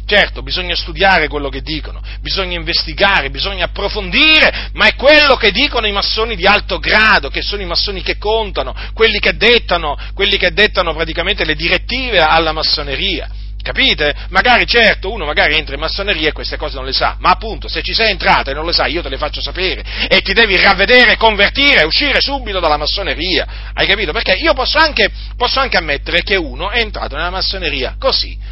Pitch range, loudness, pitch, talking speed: 165-225 Hz, -12 LUFS, 195 Hz, 190 wpm